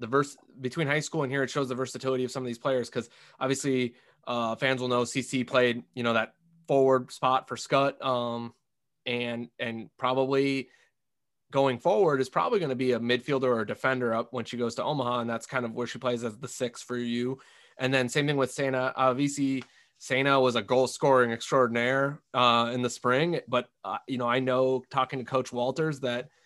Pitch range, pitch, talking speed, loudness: 120-135 Hz, 130 Hz, 210 wpm, -28 LUFS